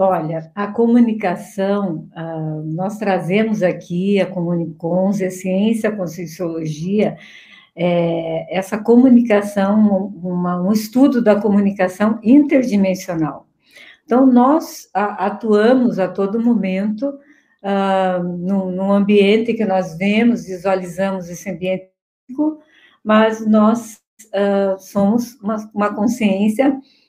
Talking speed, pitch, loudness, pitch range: 100 wpm, 200 Hz, -17 LUFS, 185-220 Hz